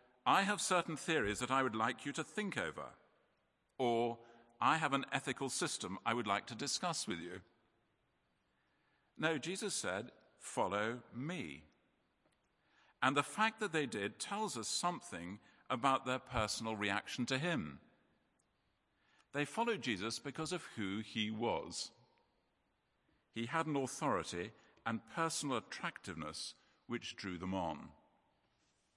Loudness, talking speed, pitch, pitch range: -39 LUFS, 135 wpm, 130 Hz, 115-160 Hz